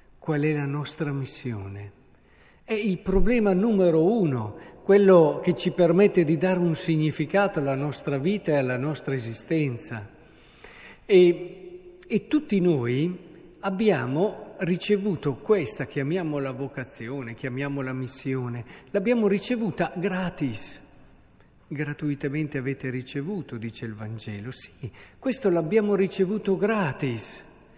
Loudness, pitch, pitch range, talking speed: -25 LUFS, 155 Hz, 135-195 Hz, 110 wpm